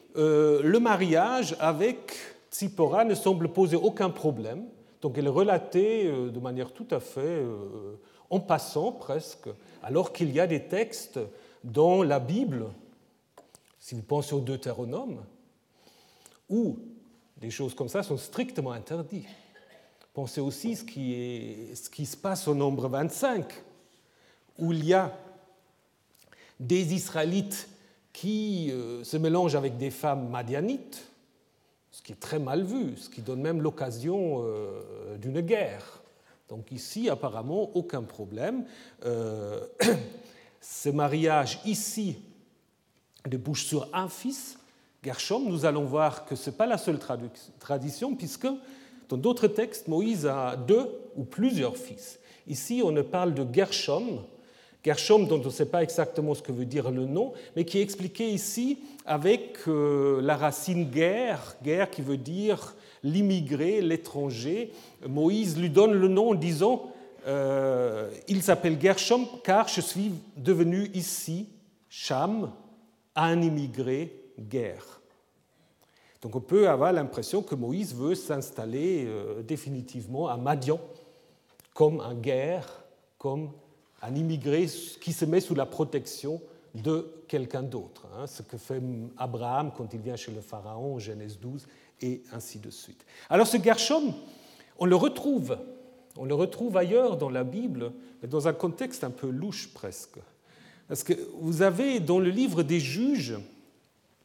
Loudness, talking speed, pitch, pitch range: -28 LUFS, 140 wpm, 165 Hz, 135-200 Hz